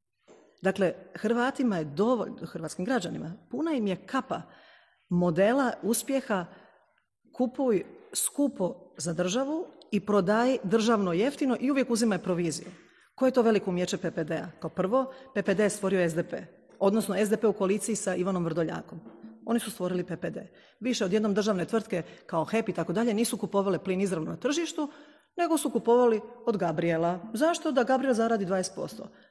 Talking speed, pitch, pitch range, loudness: 150 wpm, 210 Hz, 180-250 Hz, -28 LUFS